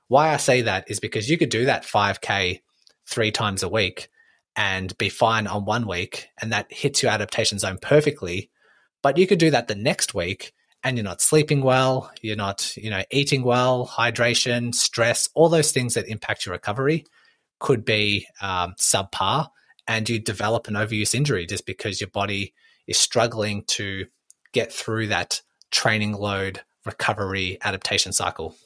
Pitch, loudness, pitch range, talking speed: 110 Hz, -22 LUFS, 100-125 Hz, 170 wpm